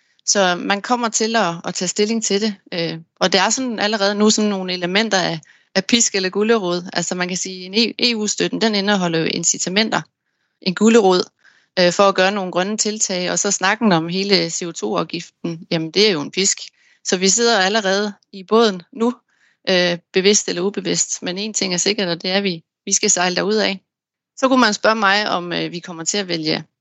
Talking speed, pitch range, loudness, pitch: 195 wpm, 180-215 Hz, -18 LUFS, 195 Hz